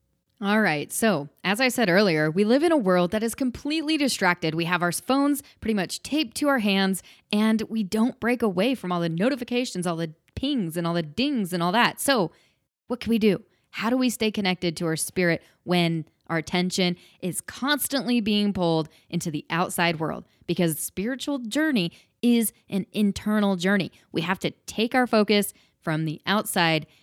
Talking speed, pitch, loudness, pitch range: 190 wpm, 200 Hz, -24 LUFS, 175-240 Hz